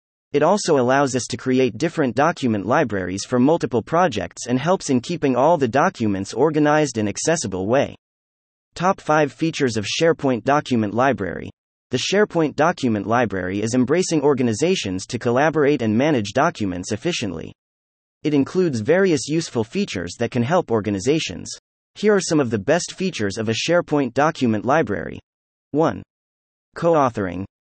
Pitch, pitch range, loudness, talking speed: 130 Hz, 110-160 Hz, -20 LUFS, 145 wpm